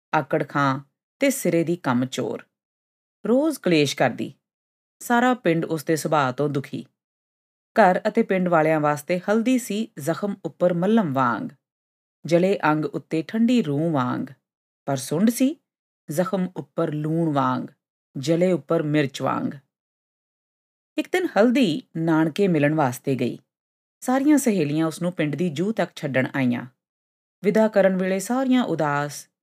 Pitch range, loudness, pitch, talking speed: 145-200 Hz, -22 LUFS, 165 Hz, 135 wpm